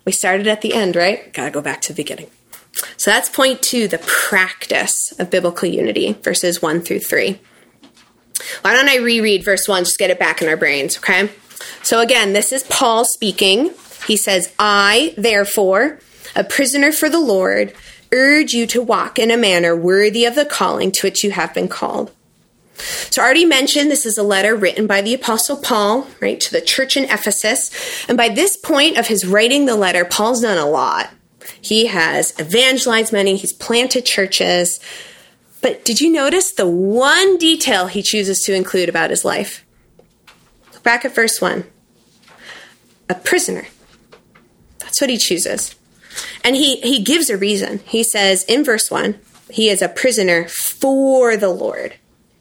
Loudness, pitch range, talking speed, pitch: -15 LUFS, 195-265 Hz, 175 wpm, 225 Hz